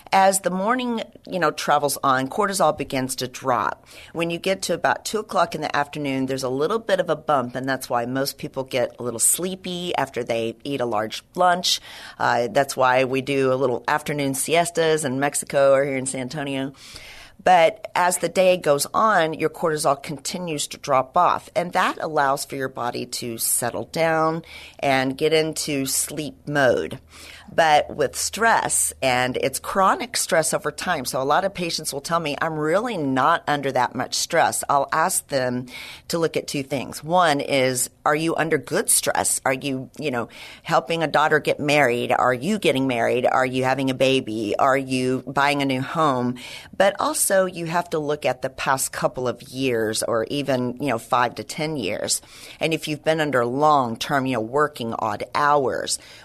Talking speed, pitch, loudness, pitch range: 190 wpm, 140 Hz, -22 LUFS, 130-160 Hz